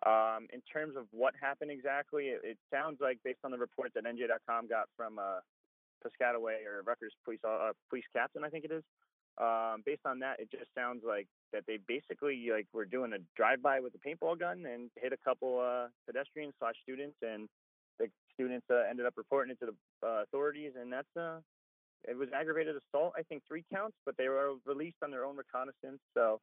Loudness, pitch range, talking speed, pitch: -38 LUFS, 120-155 Hz, 205 wpm, 135 Hz